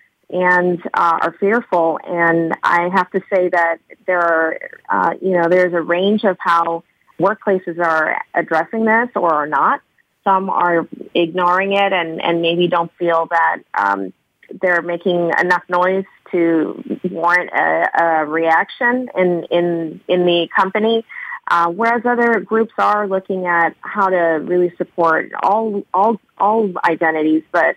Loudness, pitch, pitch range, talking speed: -16 LUFS, 175 Hz, 170-195 Hz, 145 wpm